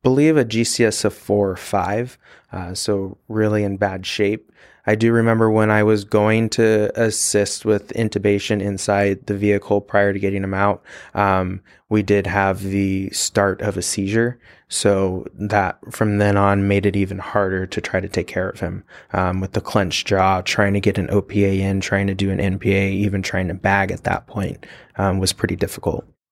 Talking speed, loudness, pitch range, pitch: 190 wpm, -19 LUFS, 95-105 Hz, 100 Hz